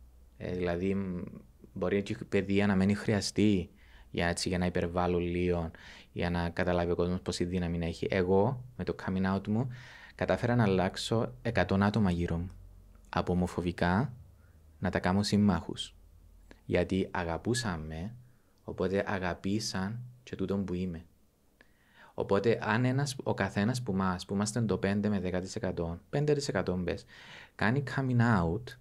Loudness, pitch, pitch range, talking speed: -31 LUFS, 95 Hz, 85-105 Hz, 140 wpm